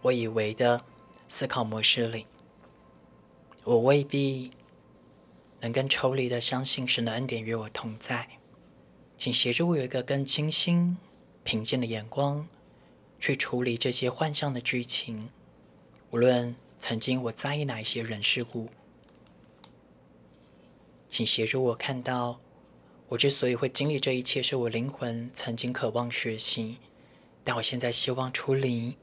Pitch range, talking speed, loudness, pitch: 115-135 Hz, 205 characters per minute, -28 LUFS, 125 Hz